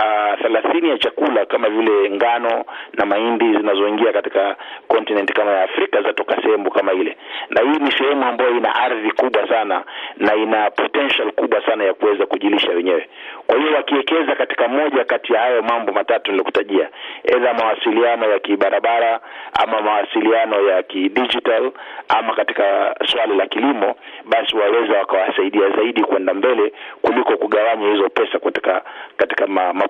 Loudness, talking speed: -17 LUFS, 145 wpm